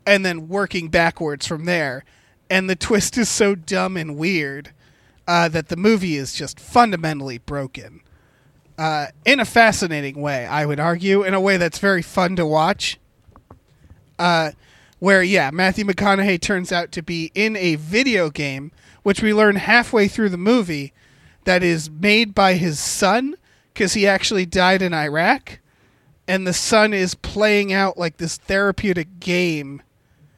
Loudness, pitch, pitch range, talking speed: -18 LUFS, 180 Hz, 150-200 Hz, 160 wpm